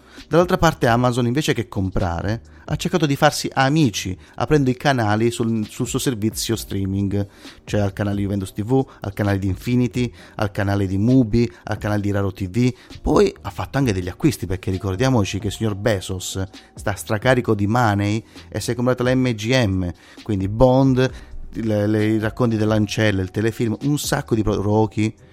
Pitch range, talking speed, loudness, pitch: 100-125 Hz, 165 wpm, -20 LUFS, 110 Hz